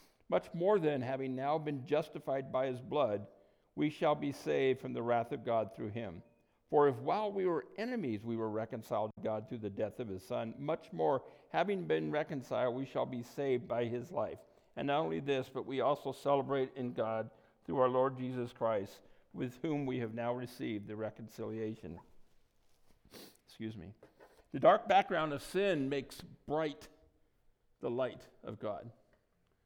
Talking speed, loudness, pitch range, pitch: 175 wpm, -36 LUFS, 110-140 Hz, 125 Hz